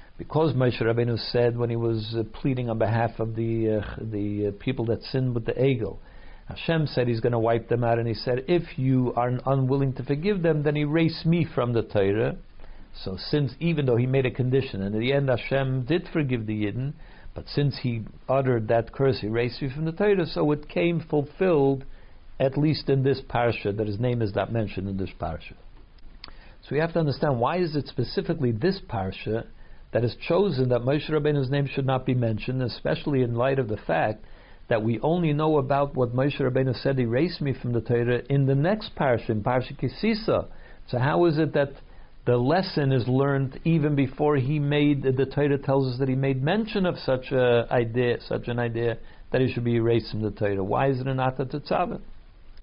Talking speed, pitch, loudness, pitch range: 210 wpm, 130 Hz, -25 LUFS, 115-145 Hz